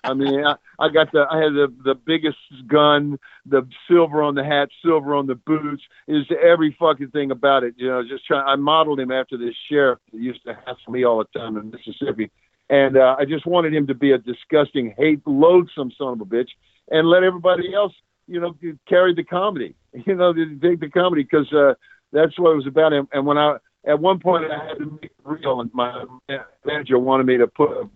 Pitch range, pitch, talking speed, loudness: 135-160 Hz, 145 Hz, 230 wpm, -19 LUFS